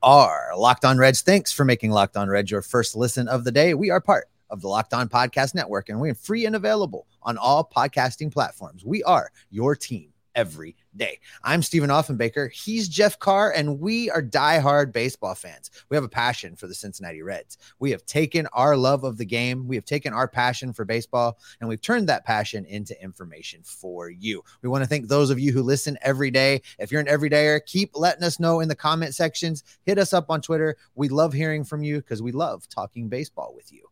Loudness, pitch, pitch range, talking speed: -22 LUFS, 140 Hz, 120-155 Hz, 225 wpm